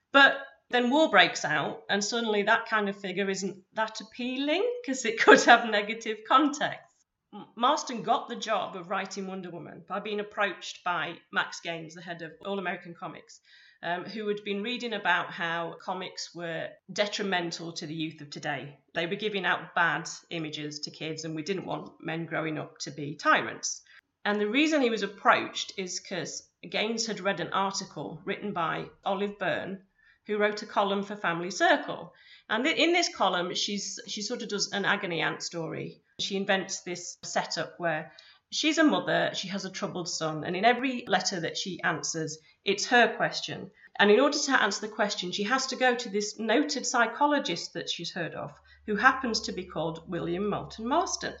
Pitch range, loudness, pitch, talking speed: 170-225 Hz, -28 LUFS, 200 Hz, 185 wpm